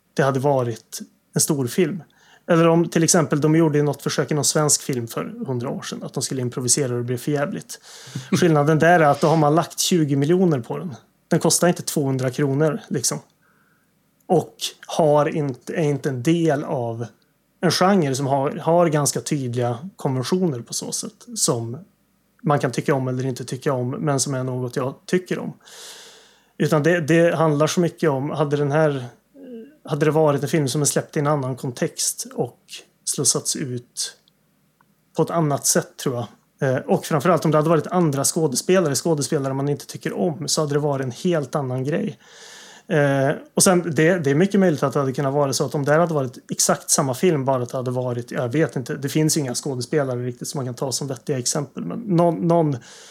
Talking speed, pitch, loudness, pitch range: 200 wpm, 155 Hz, -21 LUFS, 140-170 Hz